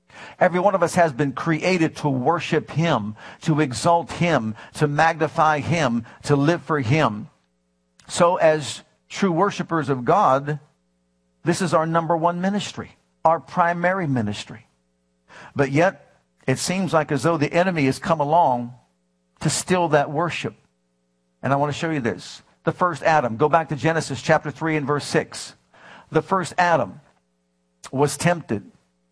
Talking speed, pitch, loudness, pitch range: 155 wpm, 150 Hz, -21 LUFS, 110-165 Hz